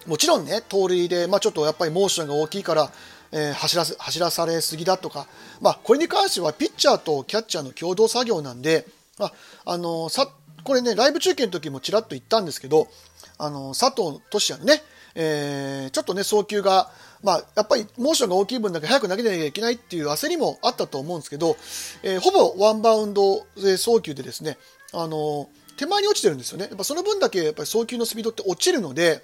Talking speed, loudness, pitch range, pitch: 460 characters per minute, -22 LUFS, 155-230 Hz, 190 Hz